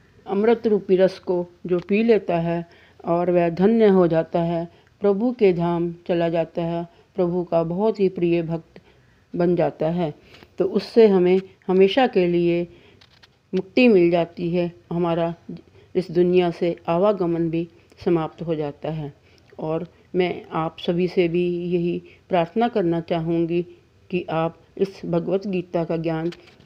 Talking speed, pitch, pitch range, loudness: 150 wpm, 175 Hz, 170-185 Hz, -22 LUFS